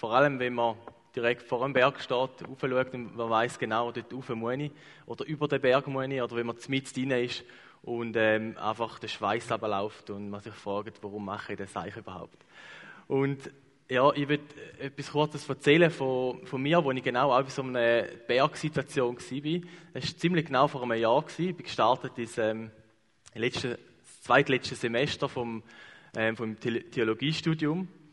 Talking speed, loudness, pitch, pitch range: 175 wpm, -29 LUFS, 125 Hz, 115-145 Hz